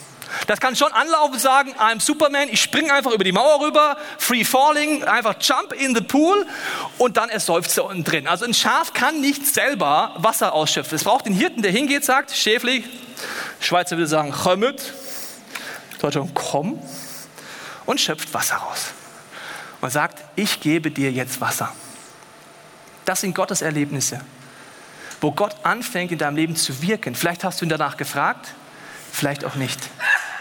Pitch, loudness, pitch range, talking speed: 210 Hz, -20 LUFS, 165-270 Hz, 160 wpm